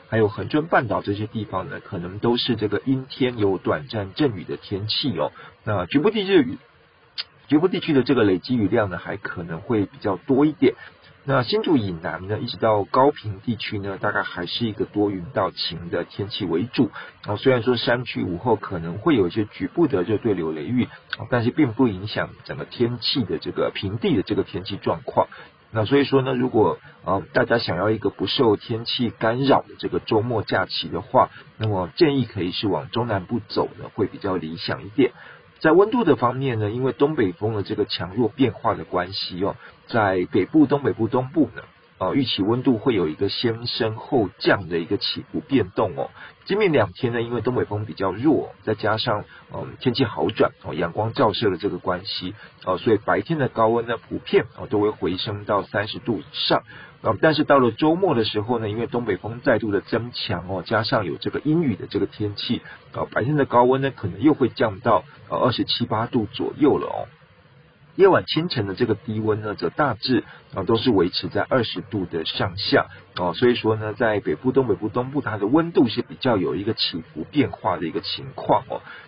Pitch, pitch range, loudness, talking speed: 115 Hz, 105-130 Hz, -22 LUFS, 305 characters per minute